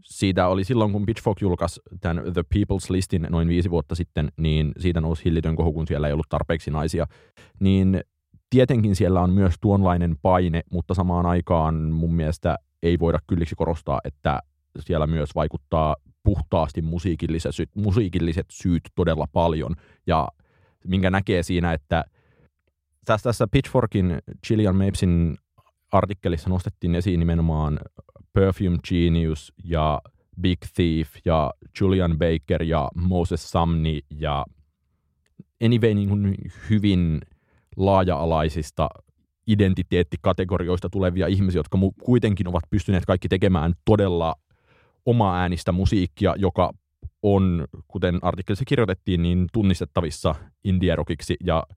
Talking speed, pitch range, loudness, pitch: 120 wpm, 80-95 Hz, -23 LUFS, 90 Hz